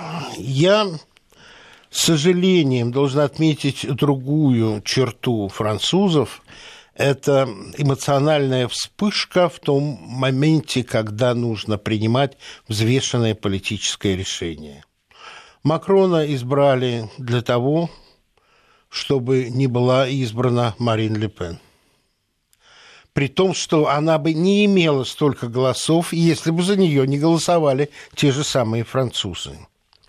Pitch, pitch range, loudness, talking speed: 135 Hz, 120-160 Hz, -19 LUFS, 100 wpm